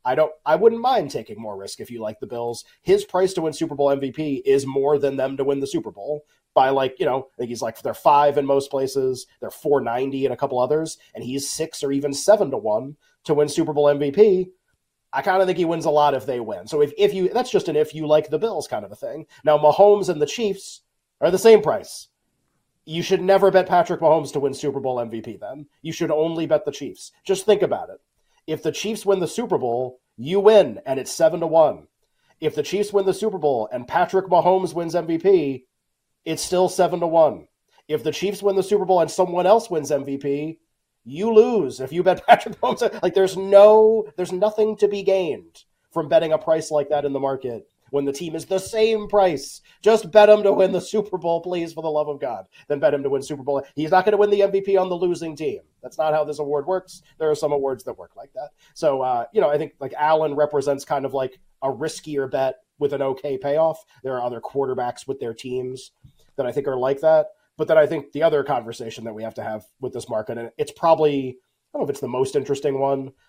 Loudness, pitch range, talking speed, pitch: -21 LUFS, 140-190 Hz, 245 wpm, 155 Hz